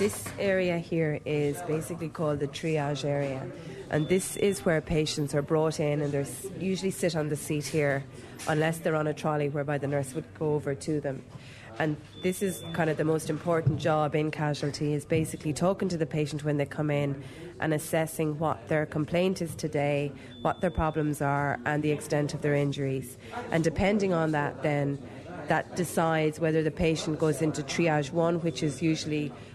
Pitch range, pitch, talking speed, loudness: 145-165 Hz, 155 Hz, 190 wpm, -29 LUFS